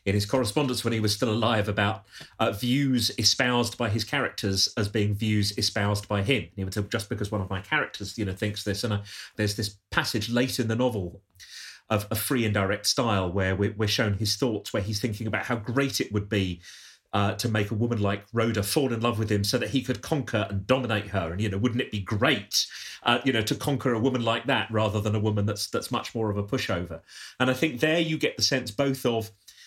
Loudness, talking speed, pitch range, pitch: -26 LUFS, 245 wpm, 105-125 Hz, 110 Hz